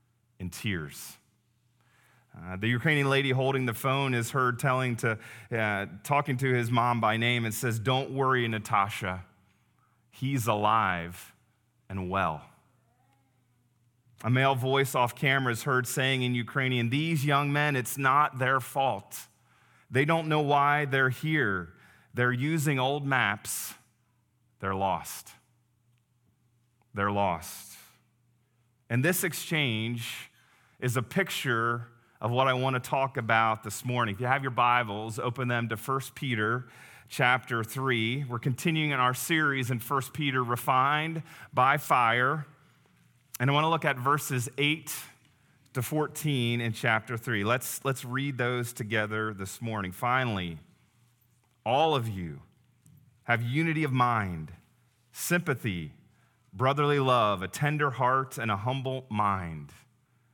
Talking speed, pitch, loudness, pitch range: 135 wpm, 125 Hz, -28 LUFS, 115-135 Hz